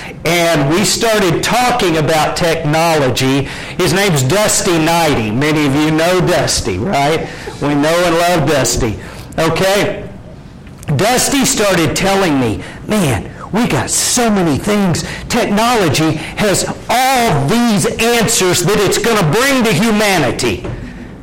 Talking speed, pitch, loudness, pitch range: 125 wpm, 170 Hz, -13 LUFS, 155-205 Hz